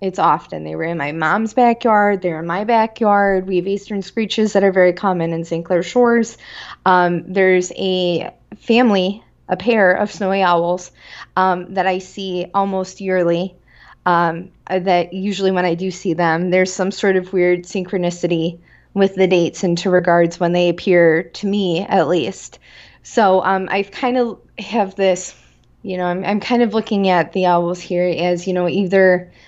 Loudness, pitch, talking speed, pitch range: -17 LUFS, 185 Hz, 180 wpm, 175-200 Hz